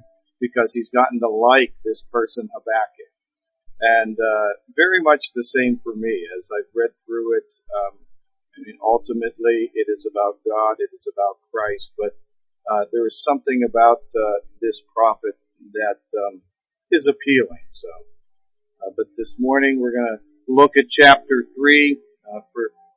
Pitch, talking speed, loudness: 145 Hz, 155 wpm, -19 LUFS